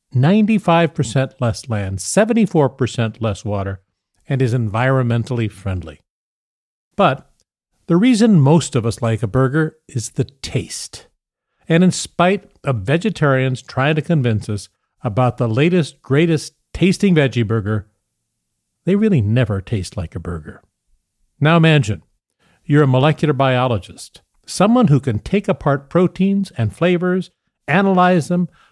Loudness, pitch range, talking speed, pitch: -17 LUFS, 115-170 Hz, 125 wpm, 135 Hz